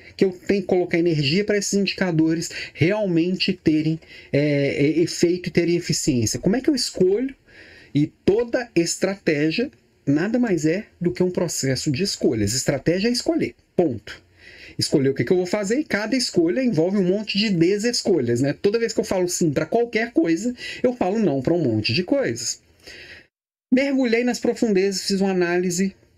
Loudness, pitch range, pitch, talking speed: -21 LUFS, 165-230 Hz, 185 Hz, 175 wpm